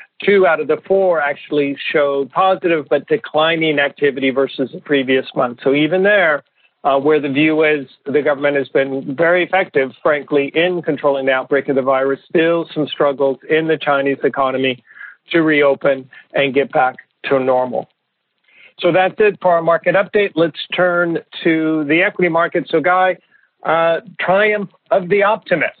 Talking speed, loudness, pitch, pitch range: 165 wpm, -16 LUFS, 155 Hz, 140-175 Hz